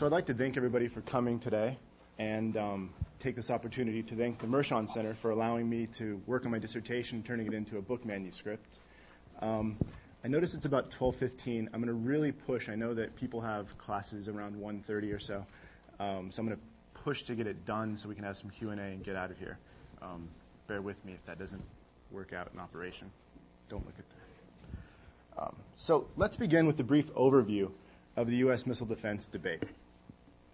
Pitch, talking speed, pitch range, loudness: 110 Hz, 205 wpm, 95-120 Hz, -35 LUFS